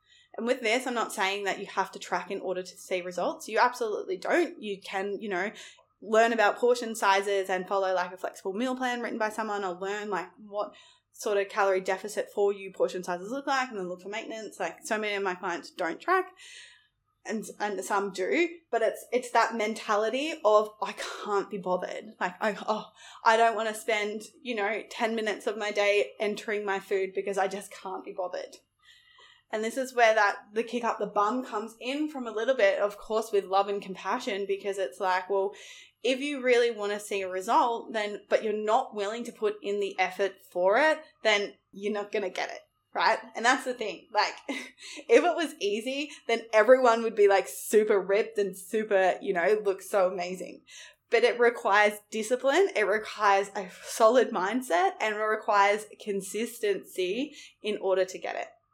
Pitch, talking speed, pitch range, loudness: 210 Hz, 200 wpm, 195-240 Hz, -28 LUFS